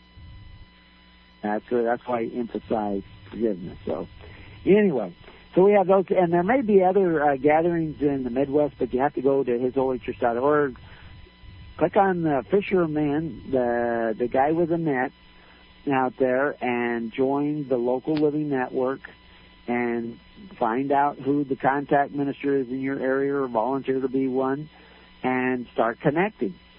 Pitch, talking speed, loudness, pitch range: 130 Hz, 150 wpm, -24 LUFS, 115-145 Hz